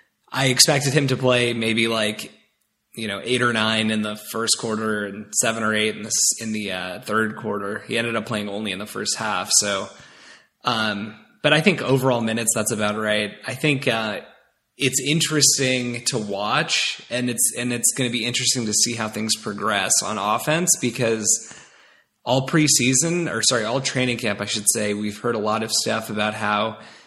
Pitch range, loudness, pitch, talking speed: 110-130 Hz, -20 LUFS, 115 Hz, 195 wpm